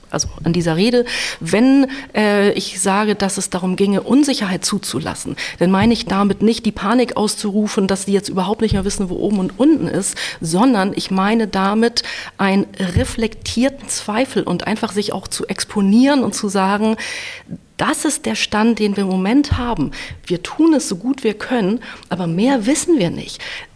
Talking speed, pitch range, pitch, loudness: 180 wpm, 195-245 Hz, 210 Hz, -17 LUFS